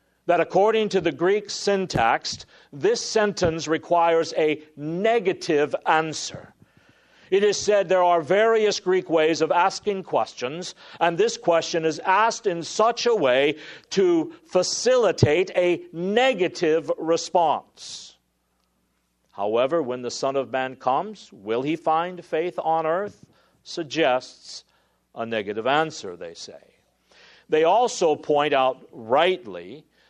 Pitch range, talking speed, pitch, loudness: 155-210 Hz, 120 wpm, 175 Hz, -22 LUFS